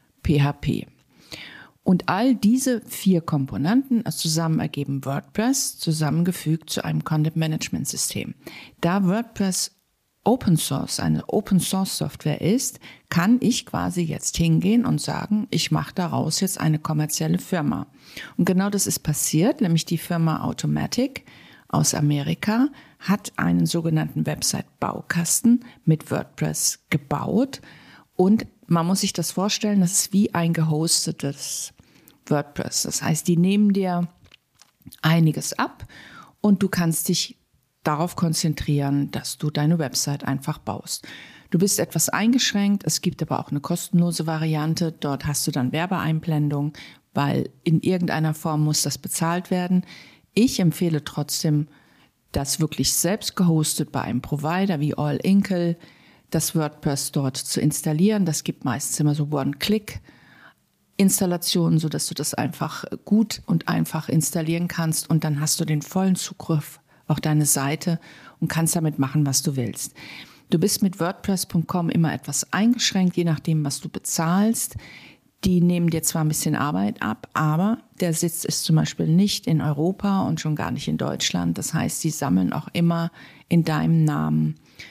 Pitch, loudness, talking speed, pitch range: 165 Hz, -23 LUFS, 145 wpm, 150-185 Hz